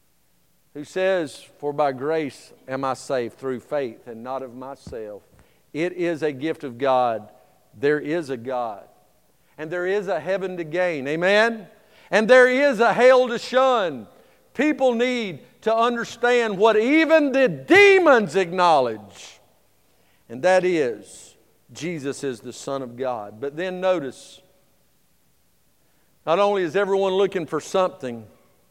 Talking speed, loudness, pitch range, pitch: 140 wpm, -21 LUFS, 135-225 Hz, 180 Hz